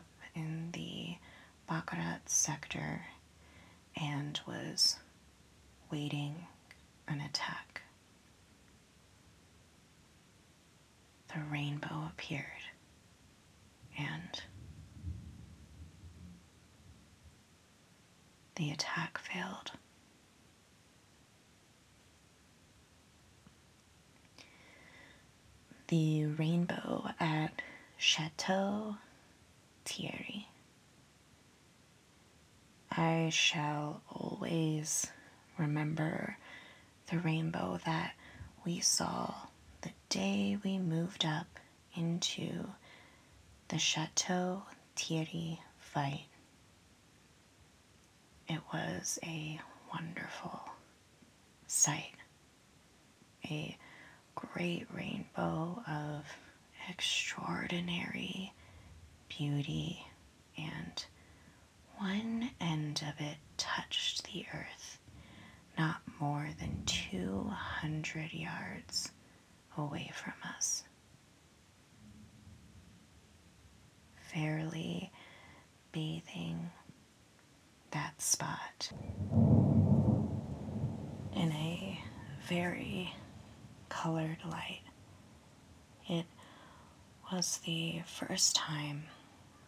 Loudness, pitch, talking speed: -37 LUFS, 150 Hz, 55 wpm